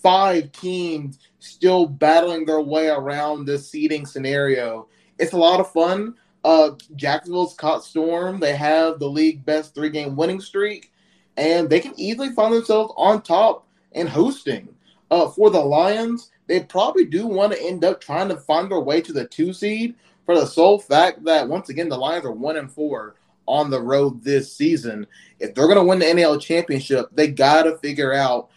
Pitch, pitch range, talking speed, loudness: 160 Hz, 150-190 Hz, 185 wpm, -19 LUFS